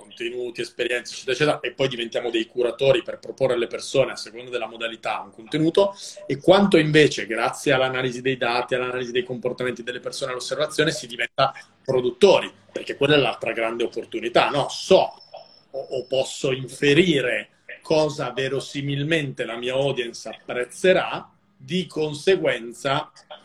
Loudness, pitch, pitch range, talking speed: -23 LUFS, 135 Hz, 125-165 Hz, 140 wpm